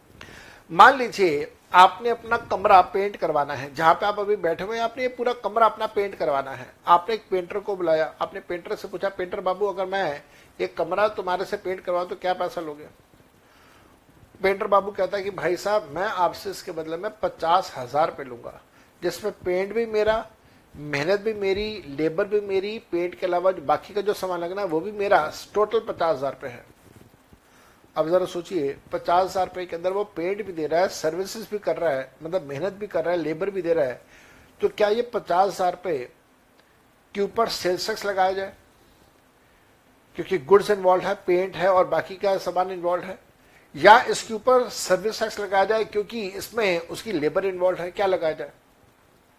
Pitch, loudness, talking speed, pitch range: 190 Hz, -24 LUFS, 190 wpm, 175-210 Hz